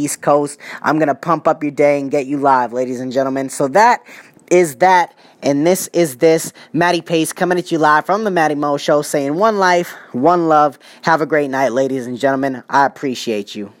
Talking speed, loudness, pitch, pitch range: 215 wpm, -15 LUFS, 150 Hz, 135-170 Hz